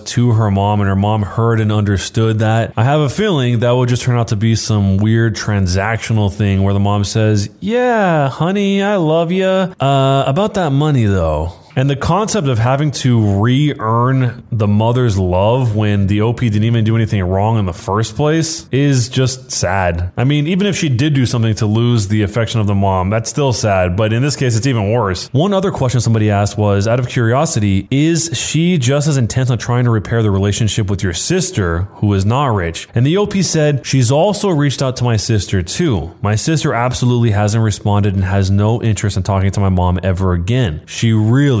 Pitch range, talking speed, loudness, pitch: 105-135 Hz, 210 wpm, -14 LUFS, 115 Hz